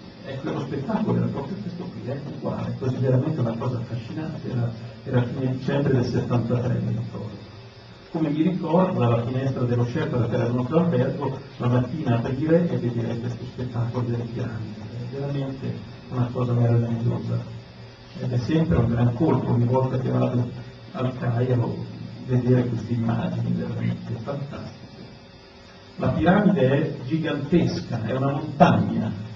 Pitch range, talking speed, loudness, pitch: 115-135 Hz, 155 wpm, -24 LUFS, 125 Hz